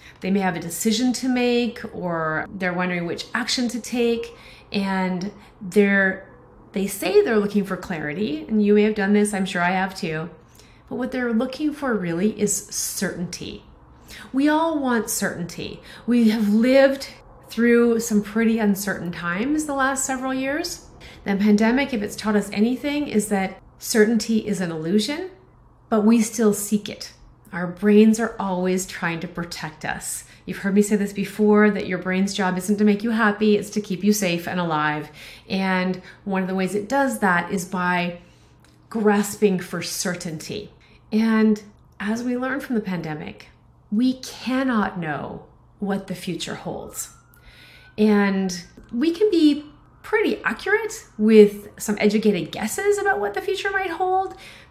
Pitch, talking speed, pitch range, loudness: 210 Hz, 160 wpm, 185-235 Hz, -22 LUFS